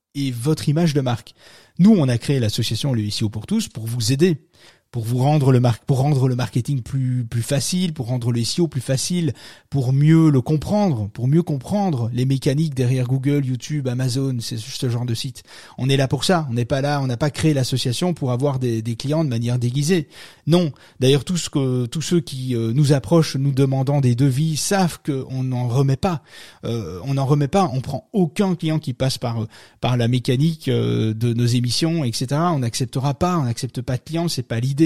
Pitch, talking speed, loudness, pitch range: 135 Hz, 215 wpm, -20 LUFS, 125-155 Hz